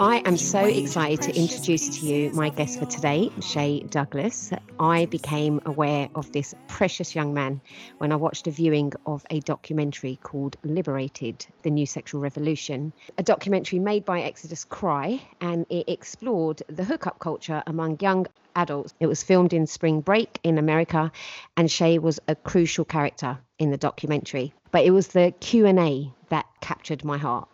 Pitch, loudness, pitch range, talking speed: 155 Hz, -25 LUFS, 145-175 Hz, 170 wpm